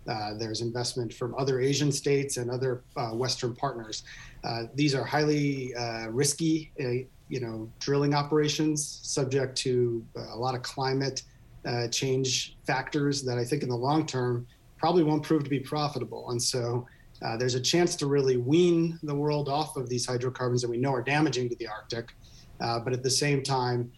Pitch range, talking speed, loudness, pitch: 120-145 Hz, 185 wpm, -29 LUFS, 130 Hz